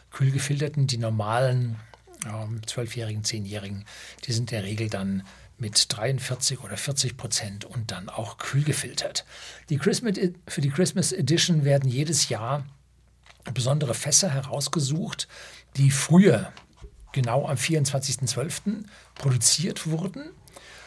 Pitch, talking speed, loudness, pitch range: 135 Hz, 110 wpm, -25 LUFS, 115-150 Hz